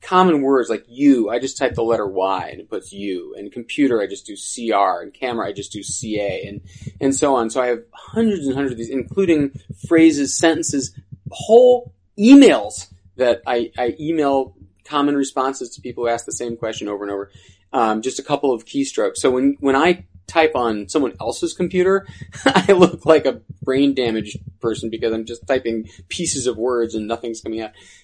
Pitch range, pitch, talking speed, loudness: 115-165 Hz, 135 Hz, 200 wpm, -18 LUFS